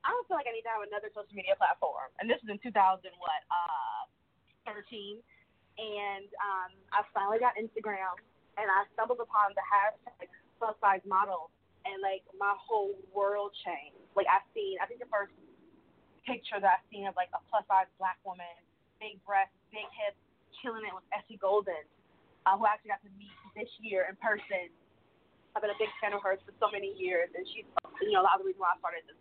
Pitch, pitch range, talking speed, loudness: 210 Hz, 195-240 Hz, 210 wpm, -33 LUFS